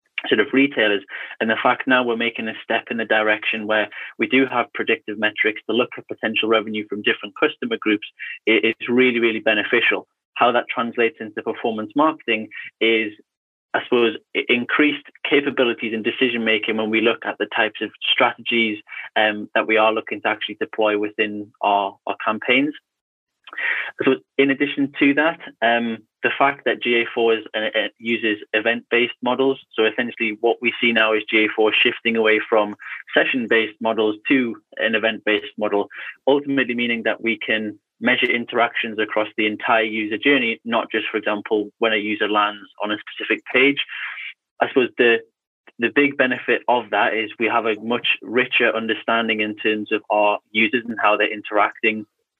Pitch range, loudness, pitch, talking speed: 110-120 Hz, -20 LUFS, 115 Hz, 170 wpm